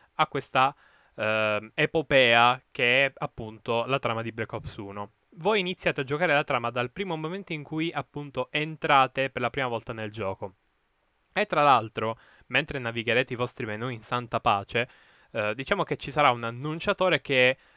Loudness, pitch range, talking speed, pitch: -26 LUFS, 115-150 Hz, 170 wpm, 130 Hz